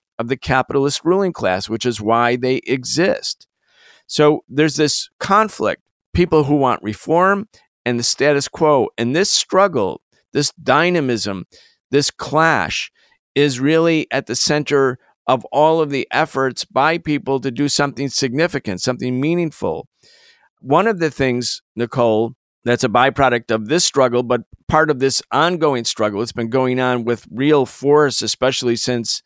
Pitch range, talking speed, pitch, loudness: 120-150 Hz, 150 wpm, 135 Hz, -17 LUFS